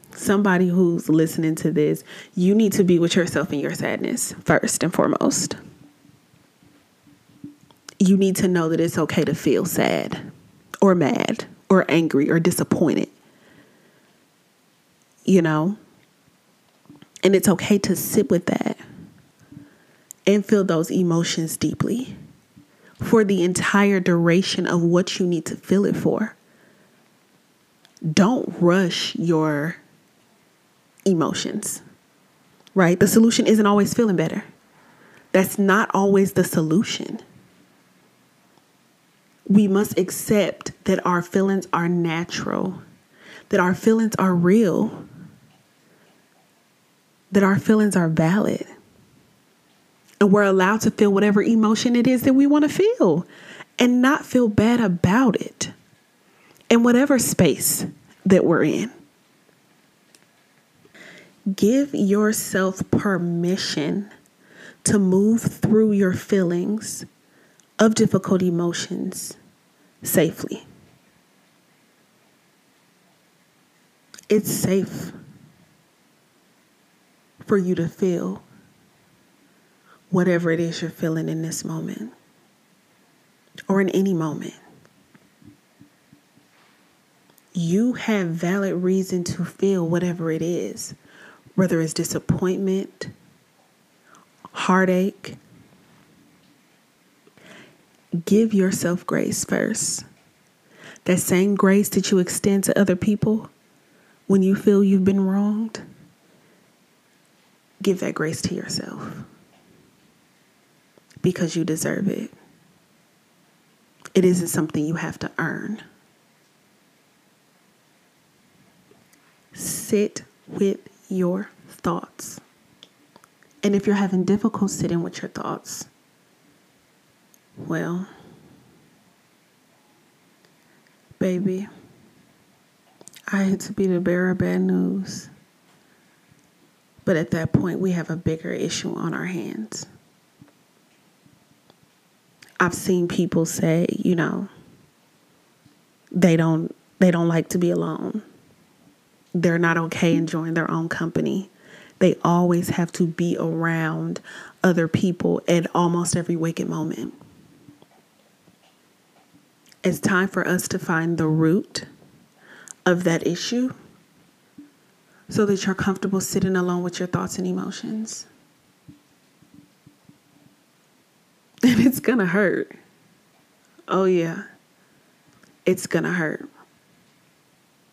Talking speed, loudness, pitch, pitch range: 100 wpm, -21 LUFS, 185 Hz, 170-205 Hz